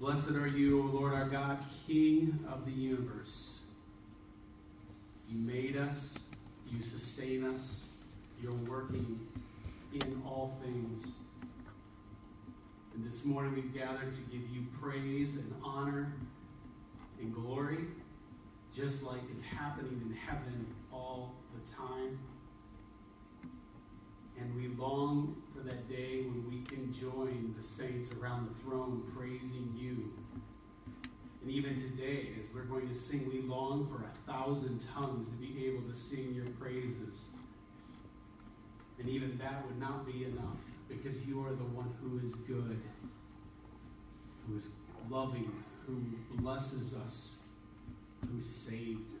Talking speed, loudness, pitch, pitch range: 130 wpm, -40 LUFS, 125 Hz, 115-135 Hz